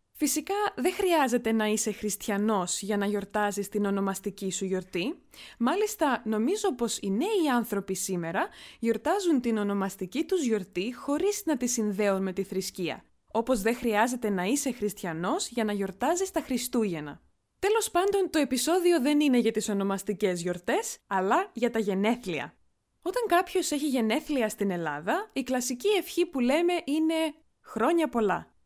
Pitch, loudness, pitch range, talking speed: 235 Hz, -28 LUFS, 200-315 Hz, 150 wpm